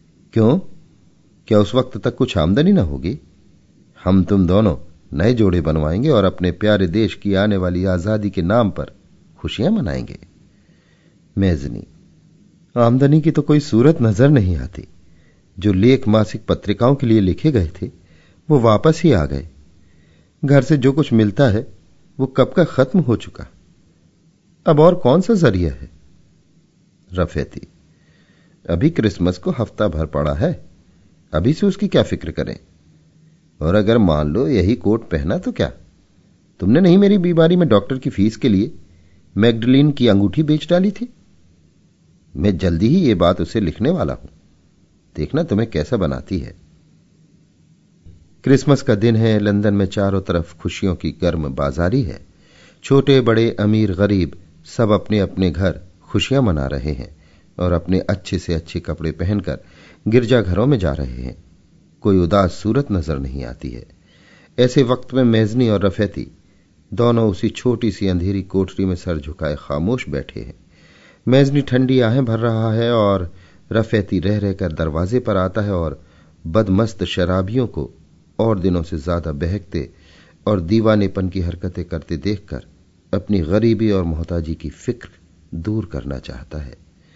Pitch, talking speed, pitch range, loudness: 100 Hz, 155 wpm, 85-115 Hz, -17 LUFS